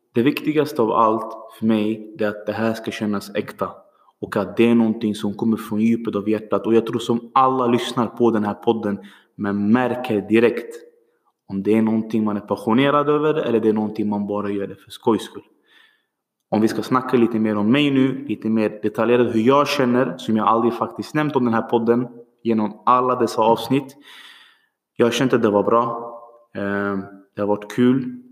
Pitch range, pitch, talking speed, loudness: 105-125 Hz, 115 Hz, 200 wpm, -20 LUFS